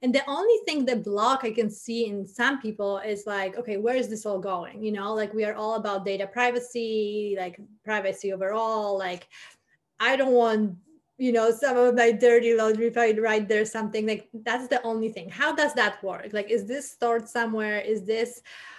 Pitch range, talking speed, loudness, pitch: 210-240 Hz, 200 wpm, -26 LUFS, 220 Hz